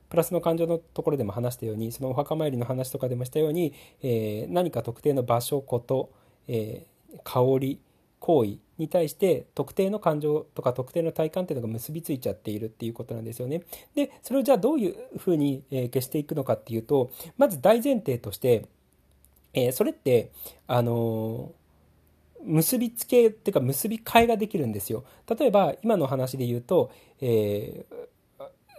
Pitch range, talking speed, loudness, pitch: 115-170 Hz, 350 characters per minute, -27 LUFS, 135 Hz